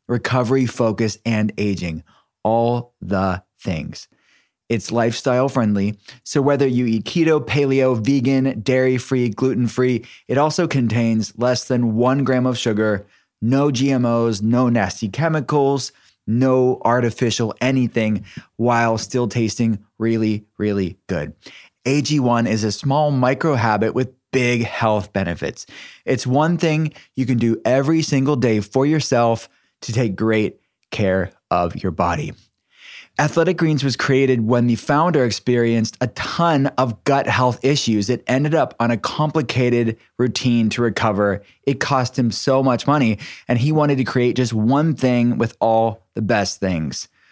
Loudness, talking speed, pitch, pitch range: -19 LUFS, 145 wpm, 120 Hz, 110-130 Hz